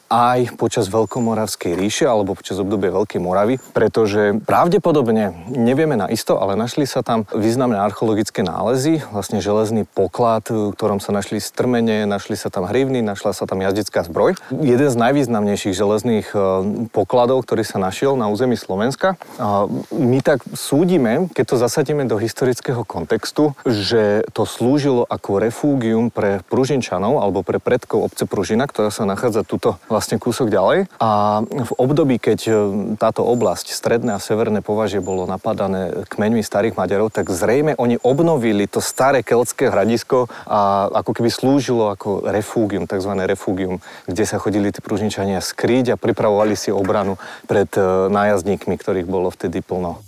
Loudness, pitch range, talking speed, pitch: -18 LUFS, 100-125 Hz, 145 wpm, 110 Hz